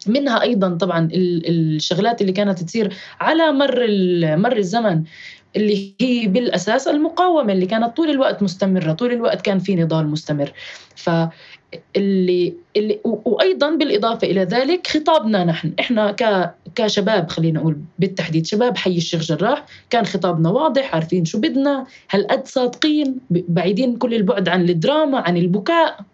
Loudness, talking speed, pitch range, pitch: -18 LUFS, 135 wpm, 175-245 Hz, 200 Hz